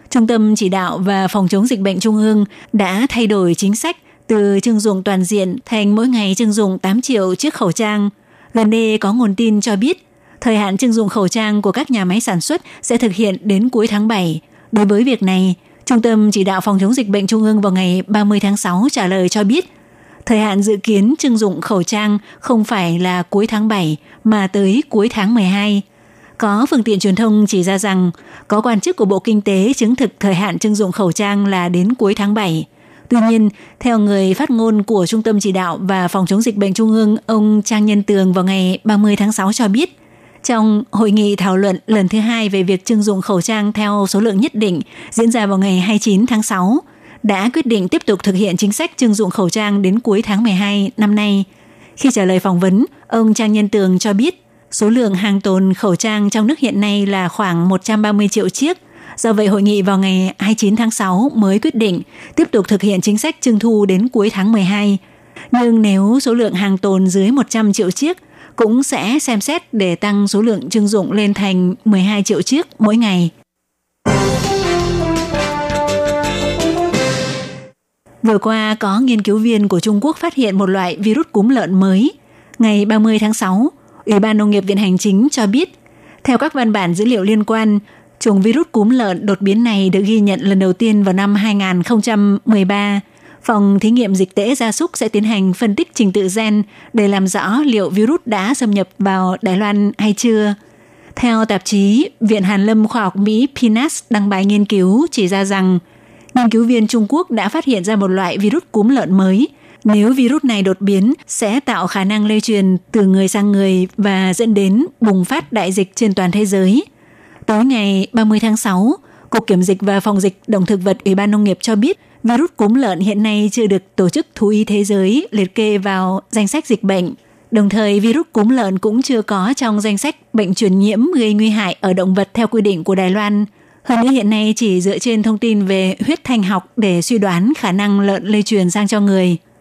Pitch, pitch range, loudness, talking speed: 210 Hz, 195-225 Hz, -14 LUFS, 220 wpm